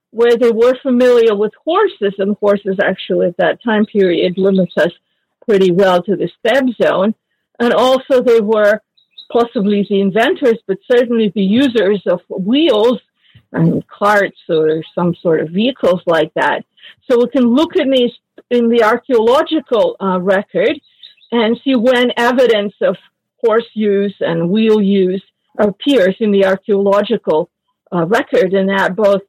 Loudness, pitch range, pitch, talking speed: -14 LUFS, 195-245 Hz, 215 Hz, 150 wpm